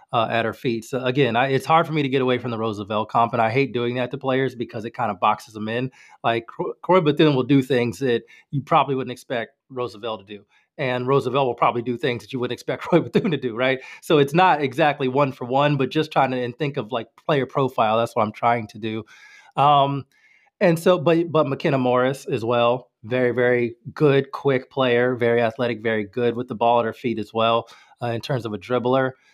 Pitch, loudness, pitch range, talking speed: 125 Hz, -22 LUFS, 115-140 Hz, 235 wpm